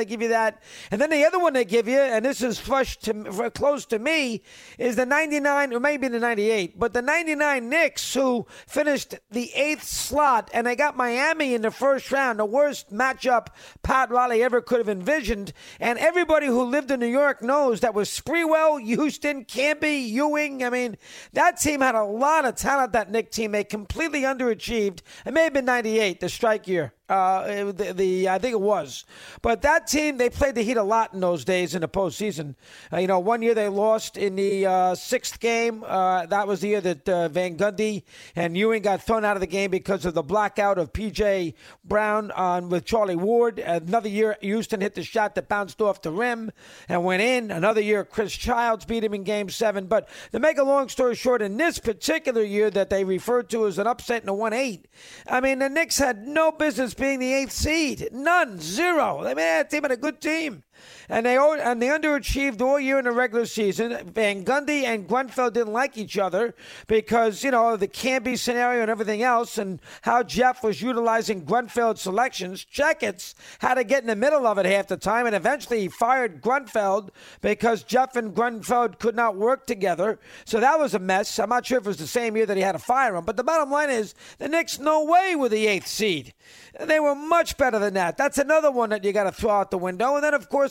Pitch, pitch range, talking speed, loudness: 235 Hz, 205-270 Hz, 220 wpm, -23 LUFS